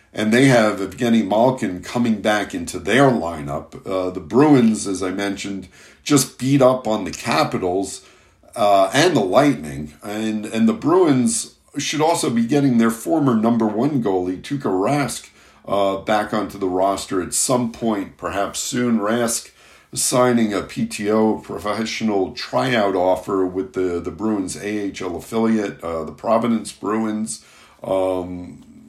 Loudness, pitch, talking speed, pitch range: -19 LUFS, 110 Hz, 145 wpm, 95-120 Hz